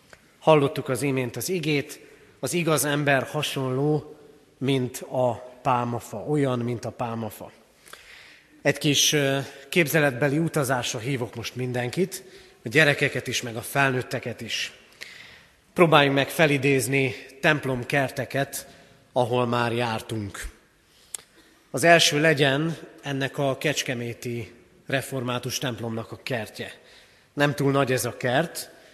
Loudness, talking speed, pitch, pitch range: -24 LUFS, 110 wpm, 135 Hz, 125-145 Hz